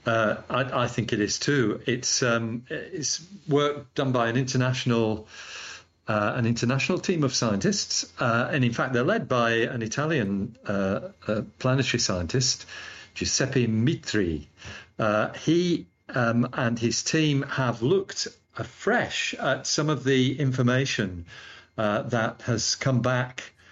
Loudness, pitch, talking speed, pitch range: -25 LUFS, 125 Hz, 140 wpm, 115-140 Hz